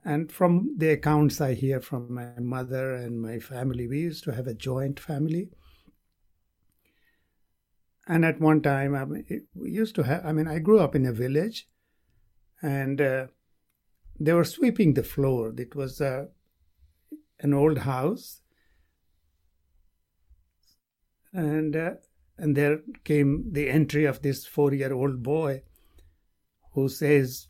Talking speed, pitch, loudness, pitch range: 145 wpm, 135 Hz, -26 LUFS, 115-155 Hz